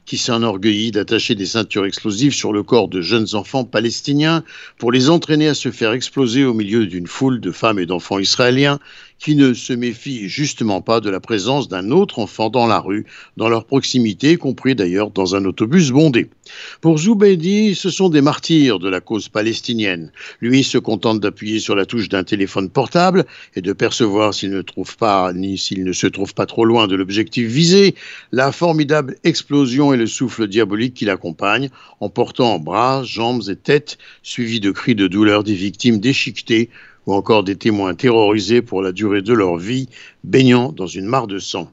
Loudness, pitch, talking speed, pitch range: -16 LUFS, 115 Hz, 190 wpm, 105-135 Hz